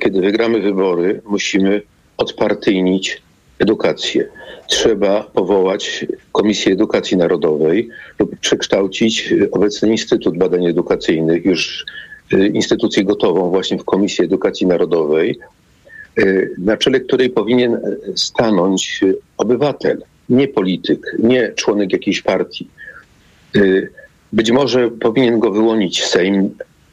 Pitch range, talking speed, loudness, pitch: 95-125 Hz, 100 wpm, -15 LUFS, 110 Hz